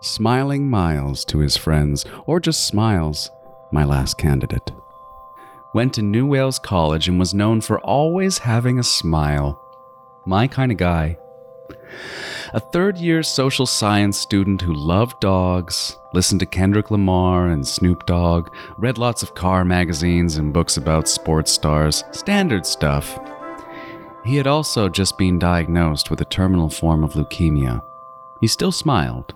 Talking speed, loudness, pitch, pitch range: 145 wpm, -19 LUFS, 95 Hz, 80-130 Hz